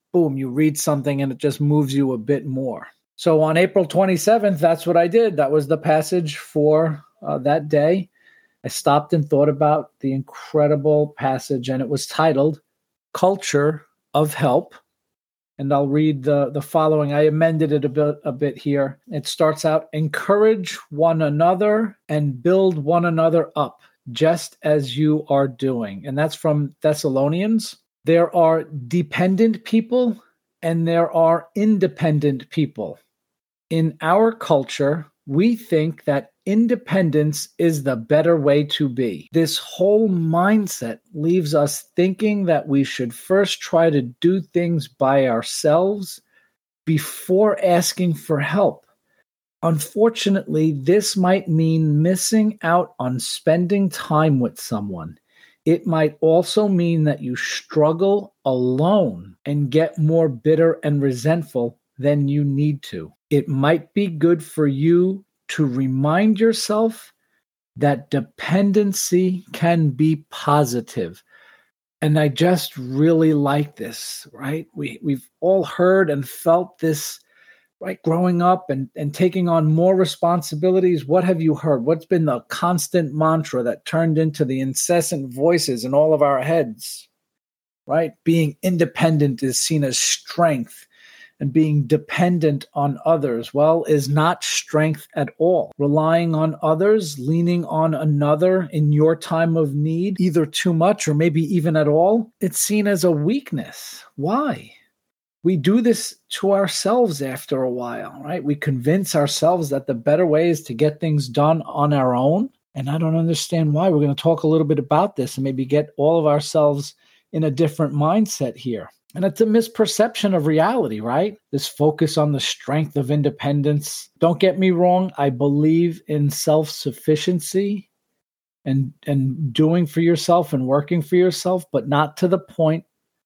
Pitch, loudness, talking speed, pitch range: 160 Hz, -19 LUFS, 150 wpm, 145-180 Hz